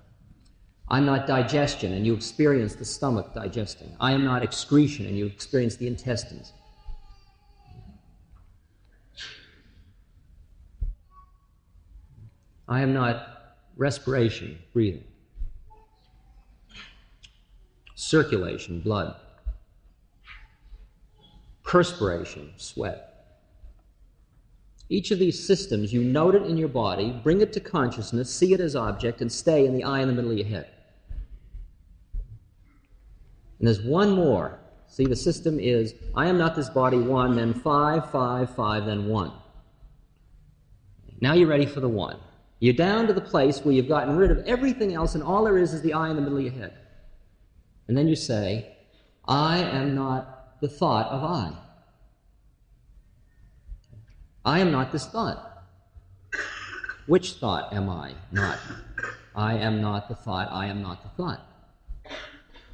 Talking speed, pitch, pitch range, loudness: 130 wpm, 115 Hz, 95-140 Hz, -25 LUFS